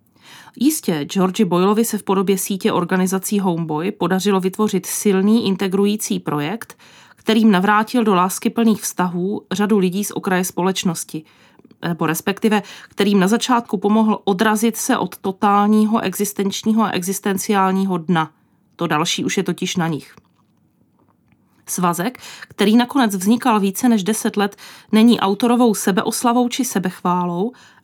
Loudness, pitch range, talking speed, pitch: -18 LUFS, 185-220 Hz, 125 wpm, 200 Hz